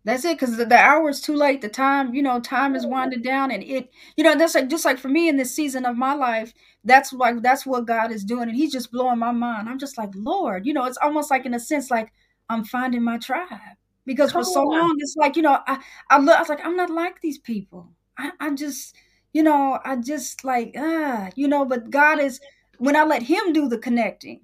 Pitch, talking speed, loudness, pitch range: 270 Hz, 255 wpm, -21 LUFS, 245-300 Hz